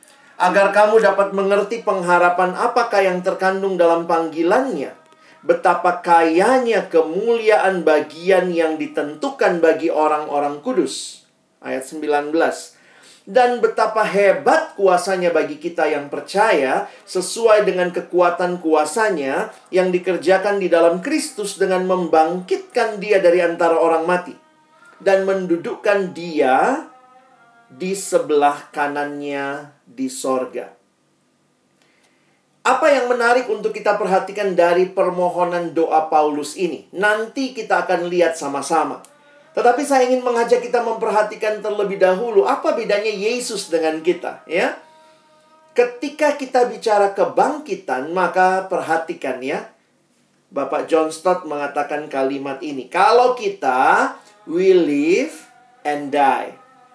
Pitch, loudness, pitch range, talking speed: 190 Hz, -18 LUFS, 165-235 Hz, 105 wpm